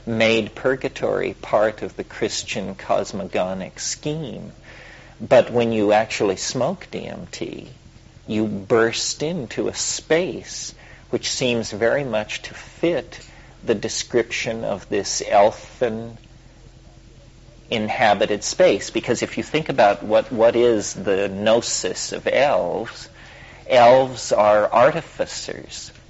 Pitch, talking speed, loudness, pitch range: 115 Hz, 110 wpm, -20 LUFS, 105-120 Hz